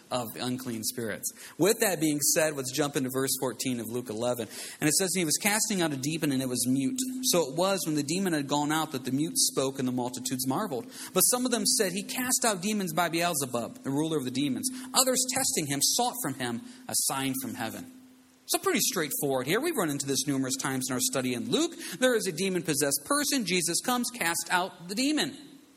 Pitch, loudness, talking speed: 170 Hz, -28 LUFS, 230 wpm